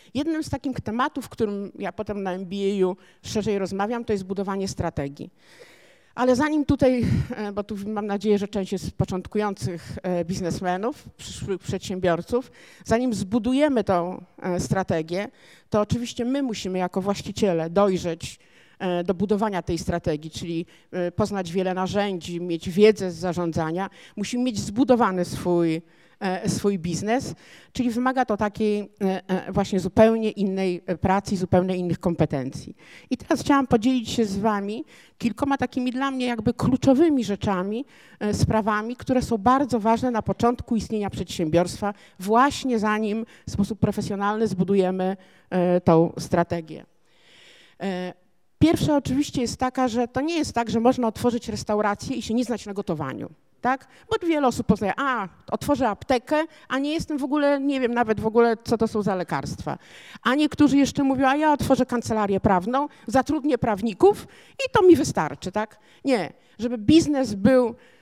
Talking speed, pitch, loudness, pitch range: 145 wpm, 210 Hz, -24 LUFS, 185-250 Hz